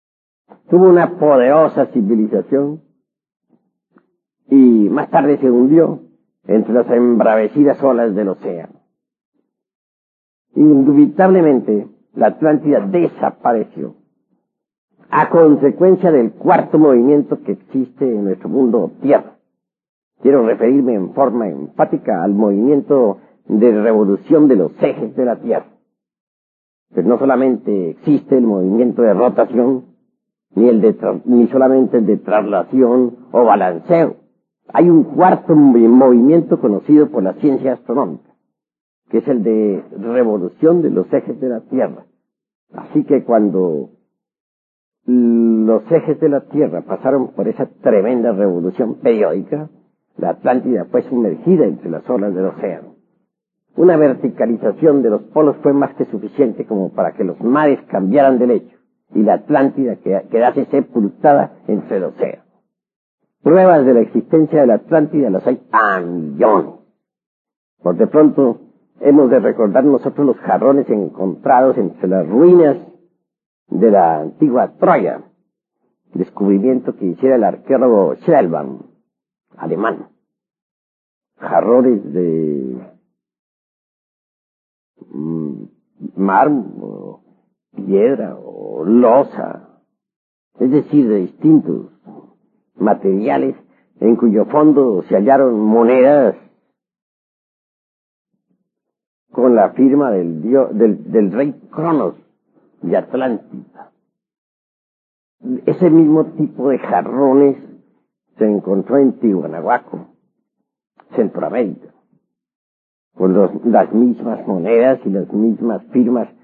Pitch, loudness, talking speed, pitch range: 125 Hz, -14 LUFS, 110 wpm, 105-150 Hz